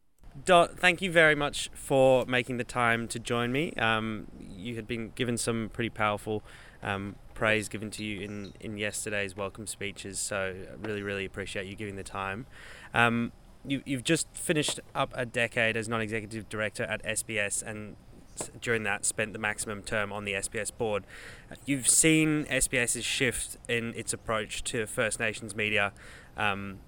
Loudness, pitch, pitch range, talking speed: -29 LUFS, 110 Hz, 105-120 Hz, 170 wpm